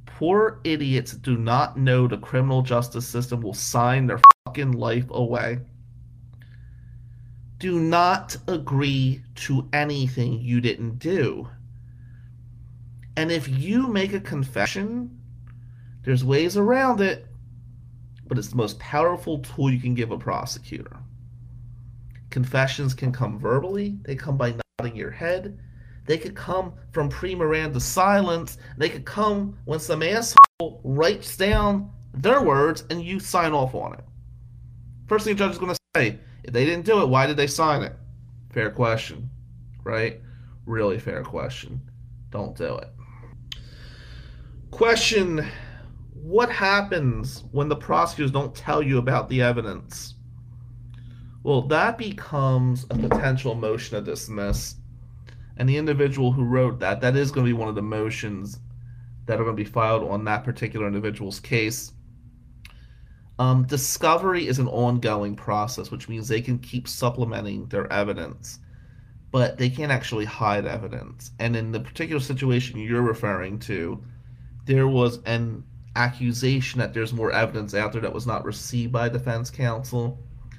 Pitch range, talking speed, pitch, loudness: 120-140 Hz, 145 wpm, 120 Hz, -23 LUFS